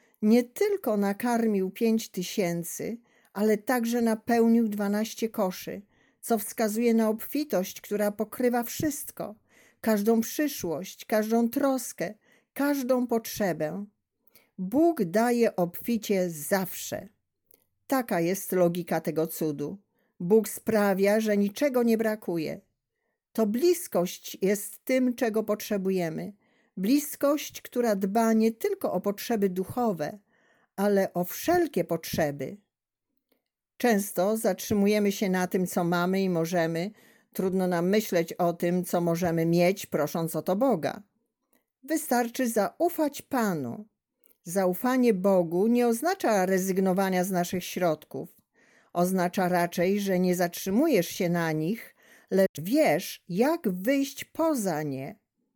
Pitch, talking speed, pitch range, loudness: 210 Hz, 110 wpm, 185-235 Hz, -27 LUFS